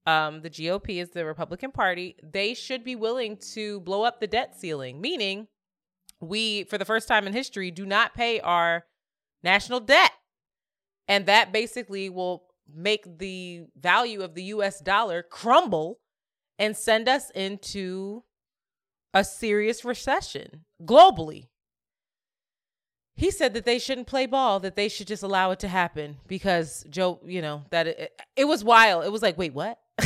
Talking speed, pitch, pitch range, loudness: 160 wpm, 200 Hz, 180-230 Hz, -24 LUFS